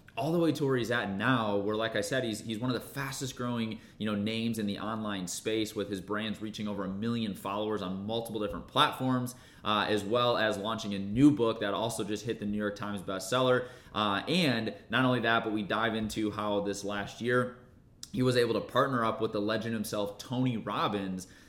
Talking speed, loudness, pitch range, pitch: 225 wpm, -31 LUFS, 105-125 Hz, 110 Hz